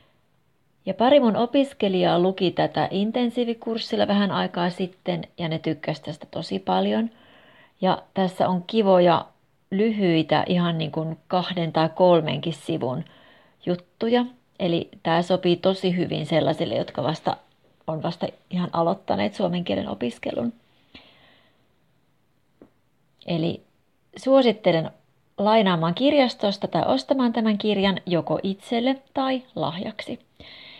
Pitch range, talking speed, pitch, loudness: 165-220 Hz, 110 wpm, 185 Hz, -23 LUFS